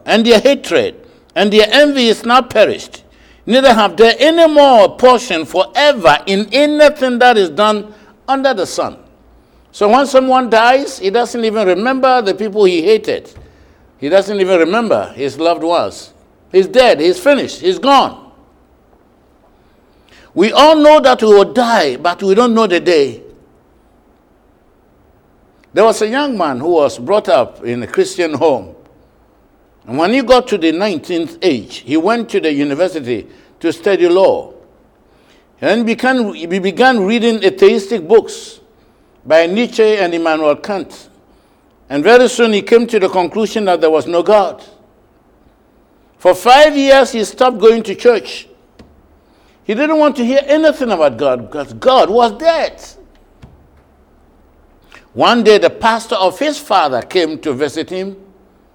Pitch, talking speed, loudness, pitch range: 225 Hz, 150 wpm, -12 LUFS, 185-270 Hz